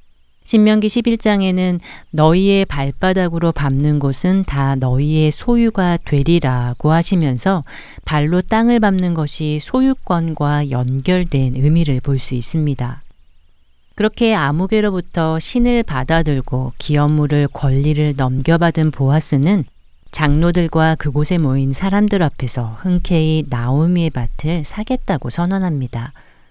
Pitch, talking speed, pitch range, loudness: 155 Hz, 270 characters per minute, 135-180 Hz, -16 LUFS